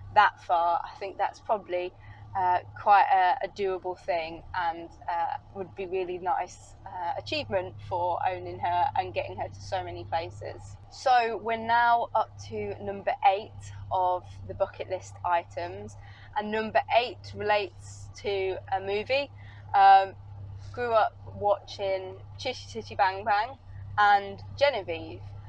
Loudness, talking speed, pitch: -28 LUFS, 140 wpm, 180 Hz